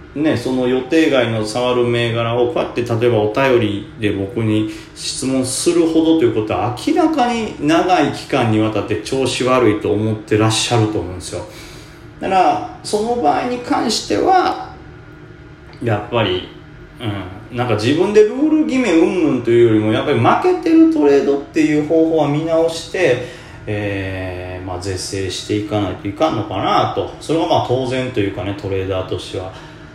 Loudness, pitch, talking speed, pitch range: -16 LUFS, 125 Hz, 350 characters per minute, 105-160 Hz